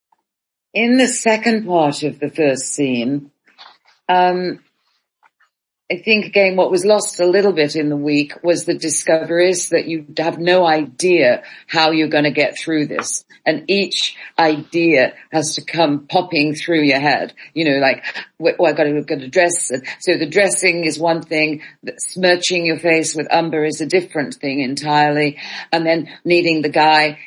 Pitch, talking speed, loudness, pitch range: 160 Hz, 170 wpm, -16 LUFS, 150-180 Hz